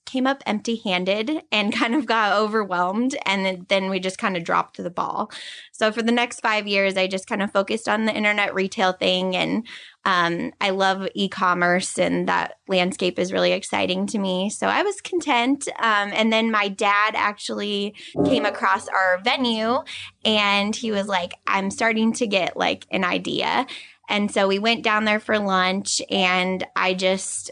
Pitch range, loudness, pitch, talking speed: 190-225 Hz, -22 LUFS, 205 Hz, 185 wpm